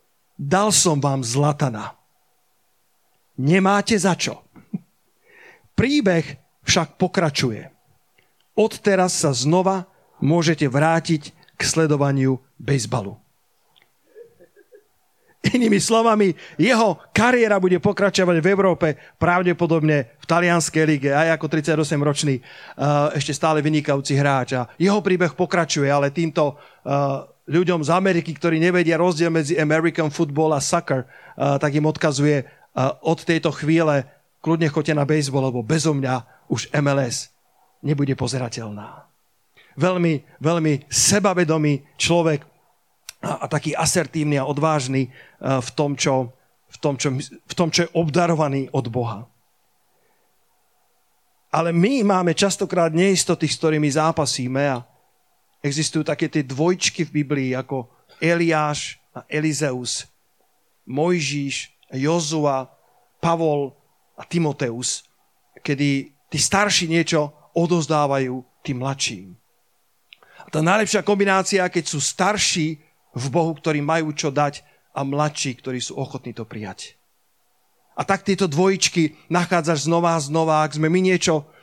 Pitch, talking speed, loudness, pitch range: 155 Hz, 115 wpm, -20 LUFS, 140-175 Hz